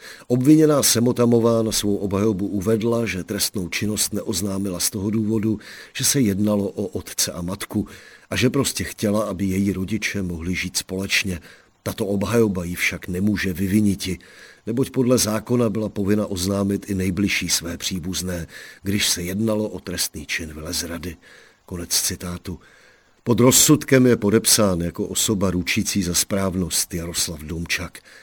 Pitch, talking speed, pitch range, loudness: 100 Hz, 140 wpm, 90-110 Hz, -21 LUFS